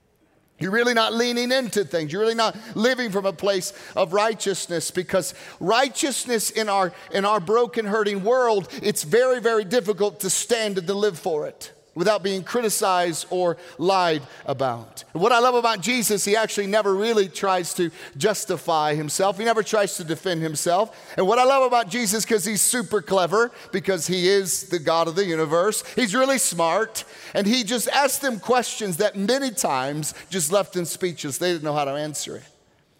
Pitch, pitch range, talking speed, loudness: 200 Hz, 180-230 Hz, 185 wpm, -22 LUFS